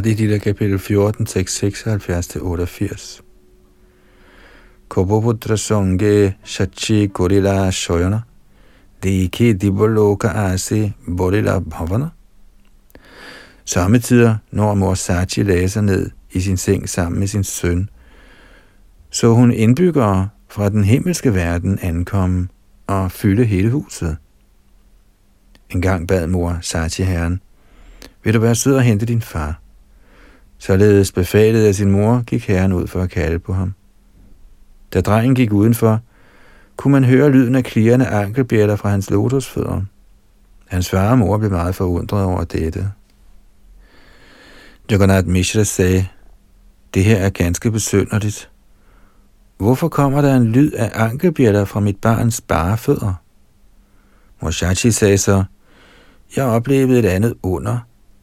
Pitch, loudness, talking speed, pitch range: 100 Hz, -16 LUFS, 120 wpm, 90-110 Hz